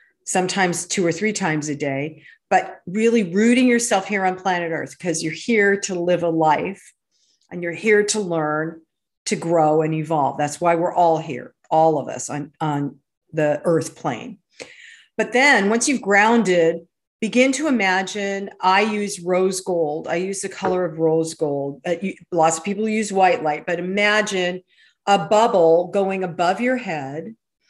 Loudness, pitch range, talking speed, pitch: -20 LUFS, 160-210 Hz, 170 wpm, 180 Hz